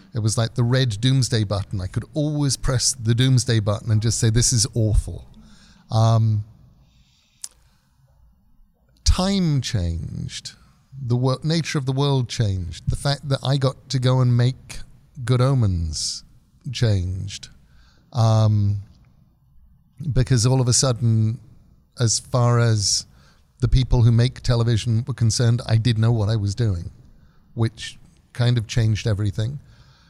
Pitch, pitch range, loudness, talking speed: 120 Hz, 110-130 Hz, -21 LUFS, 140 wpm